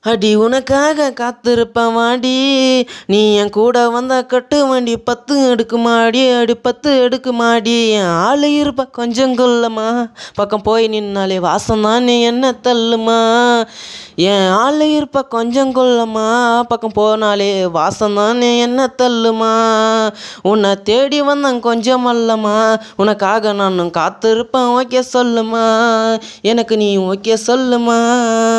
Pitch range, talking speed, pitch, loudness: 220-250 Hz, 110 wpm, 235 Hz, -13 LUFS